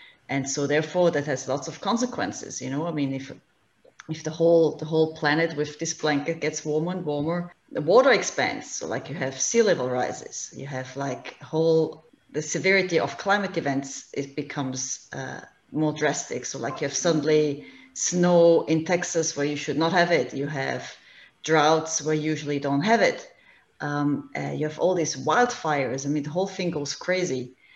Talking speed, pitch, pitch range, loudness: 190 wpm, 155 Hz, 145-170 Hz, -25 LUFS